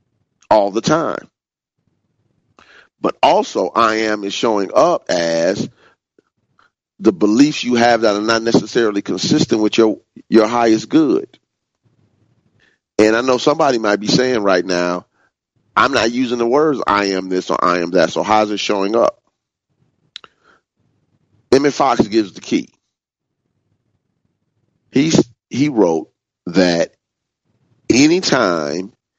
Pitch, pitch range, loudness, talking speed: 115 Hz, 105-125 Hz, -15 LUFS, 125 wpm